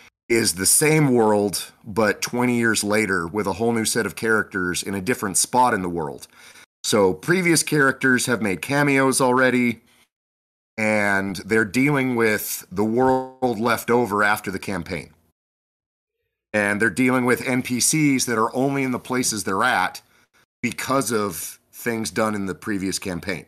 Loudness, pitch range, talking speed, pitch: -21 LUFS, 100-125 Hz, 155 wpm, 115 Hz